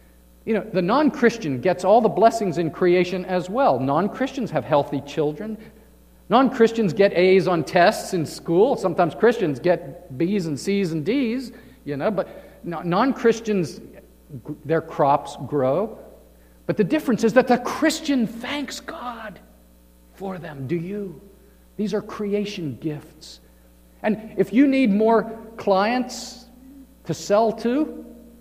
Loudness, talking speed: -21 LUFS, 145 wpm